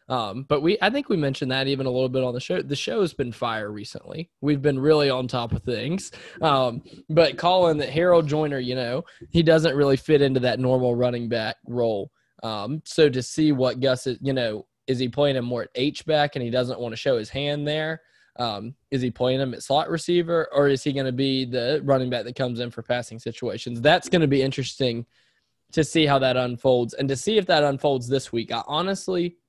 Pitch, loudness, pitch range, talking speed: 135 Hz, -23 LUFS, 125-150 Hz, 230 wpm